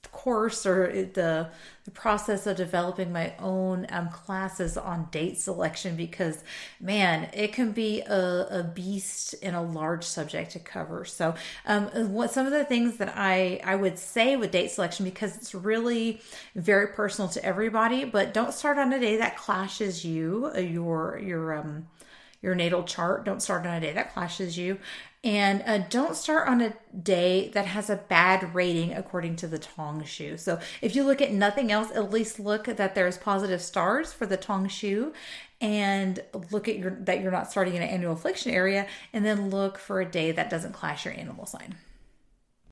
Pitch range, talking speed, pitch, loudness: 180-215 Hz, 185 wpm, 190 Hz, -28 LUFS